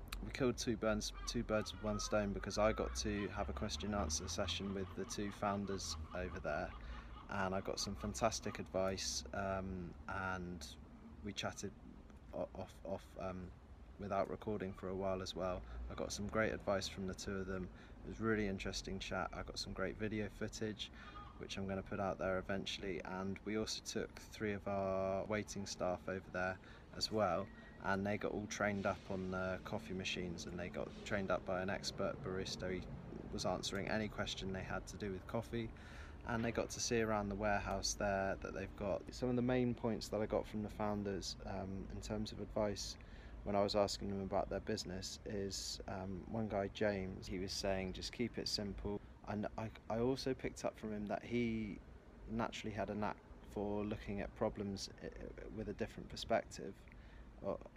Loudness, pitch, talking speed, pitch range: -42 LUFS, 100 Hz, 195 wpm, 95-105 Hz